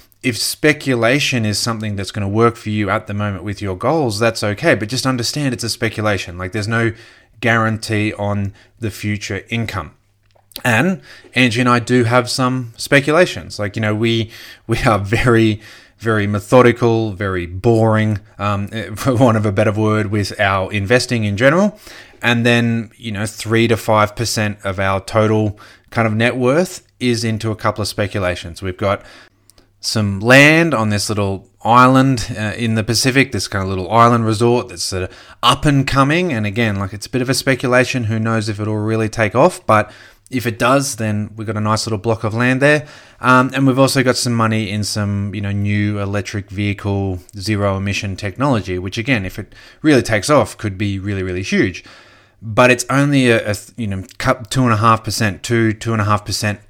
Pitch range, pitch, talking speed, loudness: 105-120 Hz, 110 Hz, 195 wpm, -16 LUFS